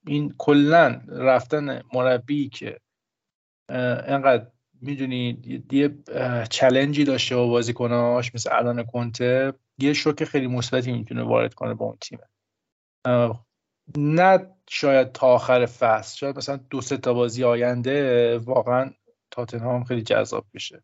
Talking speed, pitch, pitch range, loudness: 120 wpm, 130 Hz, 120-140 Hz, -22 LUFS